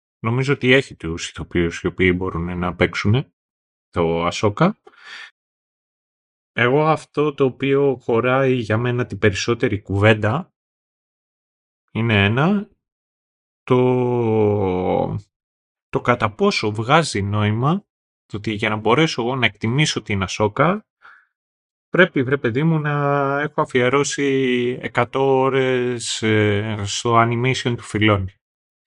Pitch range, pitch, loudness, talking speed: 105-140 Hz, 120 Hz, -19 LUFS, 110 wpm